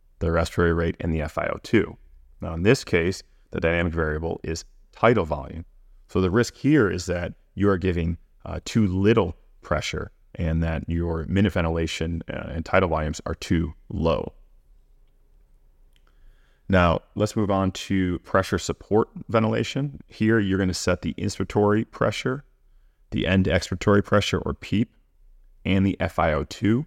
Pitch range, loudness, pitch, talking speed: 80-100 Hz, -24 LUFS, 90 Hz, 145 wpm